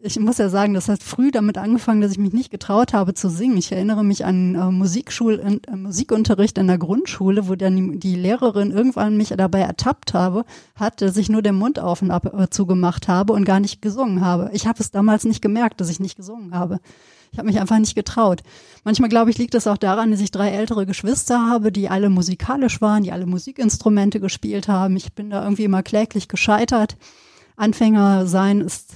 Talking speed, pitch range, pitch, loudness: 215 wpm, 190-220 Hz, 205 Hz, -19 LUFS